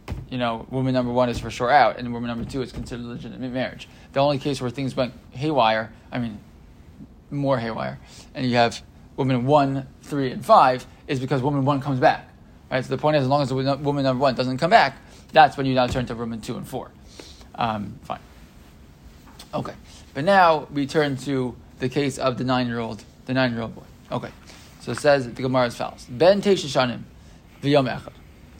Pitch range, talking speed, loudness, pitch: 120-140 Hz, 195 wpm, -22 LUFS, 130 Hz